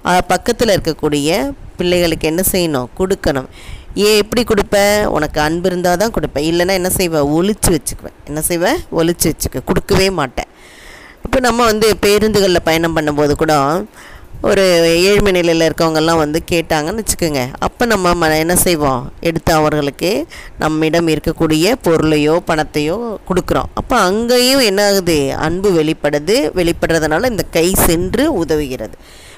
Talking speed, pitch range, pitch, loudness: 125 wpm, 155-190 Hz, 170 Hz, -14 LUFS